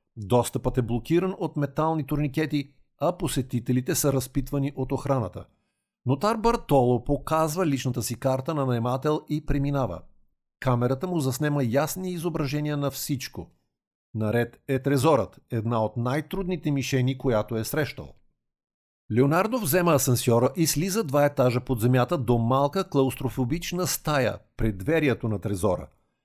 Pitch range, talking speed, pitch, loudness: 120-155 Hz, 130 wpm, 135 Hz, -26 LUFS